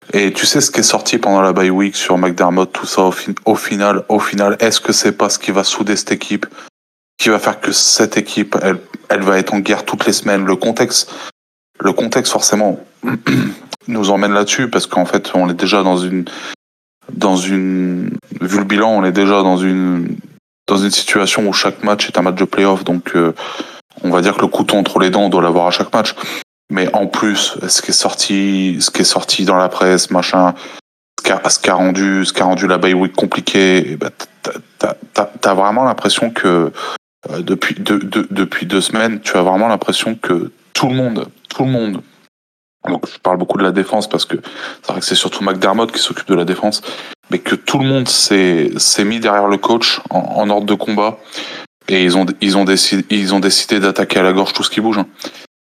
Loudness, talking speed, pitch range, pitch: -13 LUFS, 225 wpm, 90-100 Hz, 95 Hz